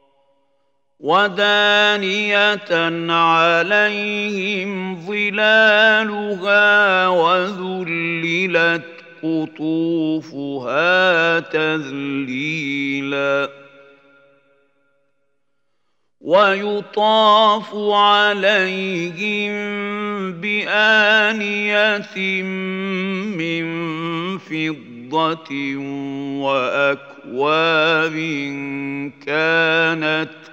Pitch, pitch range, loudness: 165 Hz, 140-205 Hz, -17 LUFS